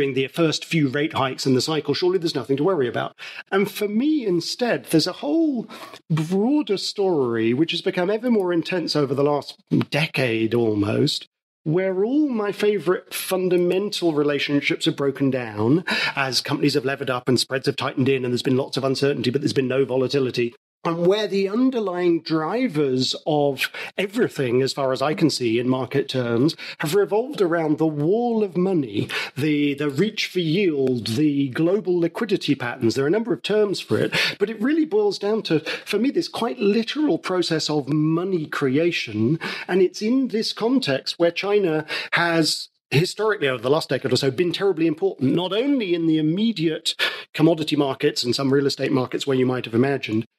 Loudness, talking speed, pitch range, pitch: -22 LUFS, 185 wpm, 135-195 Hz, 160 Hz